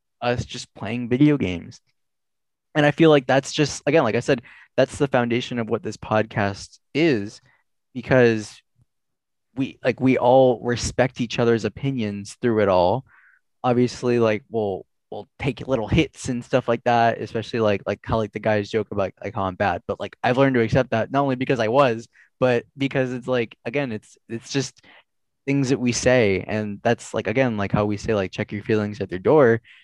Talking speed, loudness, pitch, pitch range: 195 wpm, -22 LUFS, 120 Hz, 110-130 Hz